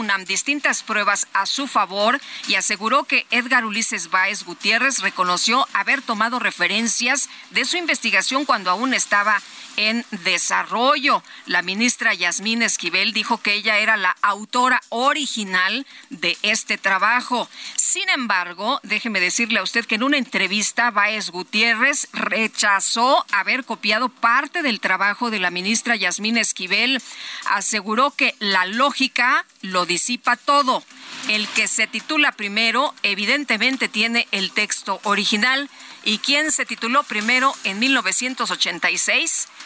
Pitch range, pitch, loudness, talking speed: 200-255 Hz, 225 Hz, -18 LUFS, 130 wpm